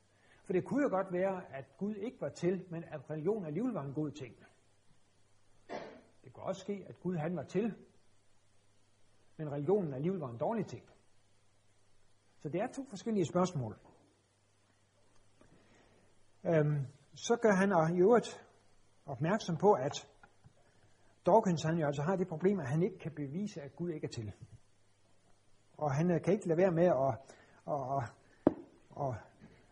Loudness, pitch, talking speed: -35 LUFS, 150 Hz, 155 wpm